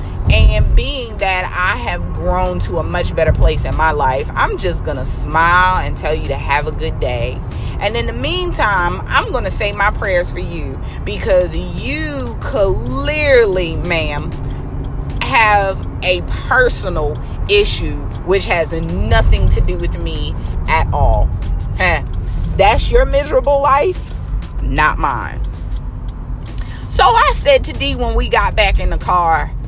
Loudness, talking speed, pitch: -16 LUFS, 150 wpm, 170 Hz